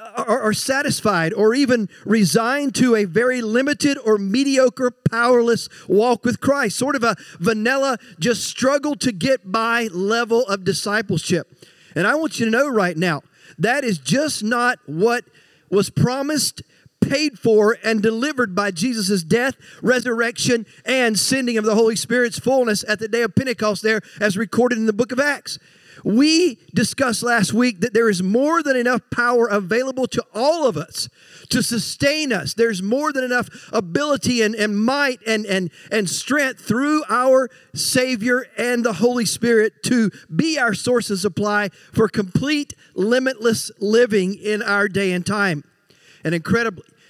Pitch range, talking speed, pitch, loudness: 205-250 Hz, 160 wpm, 230 Hz, -19 LUFS